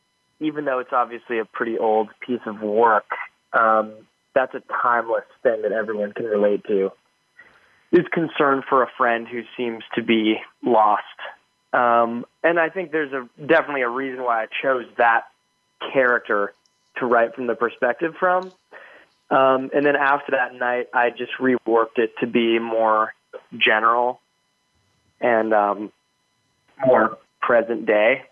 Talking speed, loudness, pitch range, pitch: 145 wpm, -21 LUFS, 110-135 Hz, 120 Hz